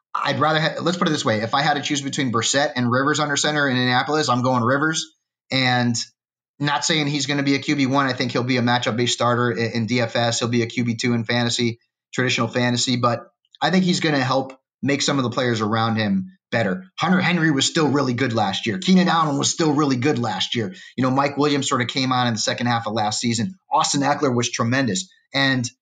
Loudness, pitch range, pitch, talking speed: -20 LUFS, 120-150 Hz, 130 Hz, 245 wpm